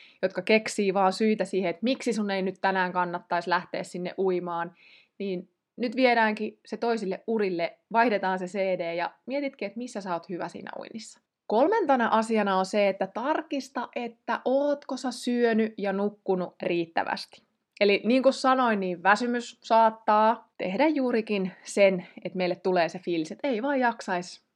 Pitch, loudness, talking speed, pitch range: 205 Hz, -27 LUFS, 160 wpm, 185-240 Hz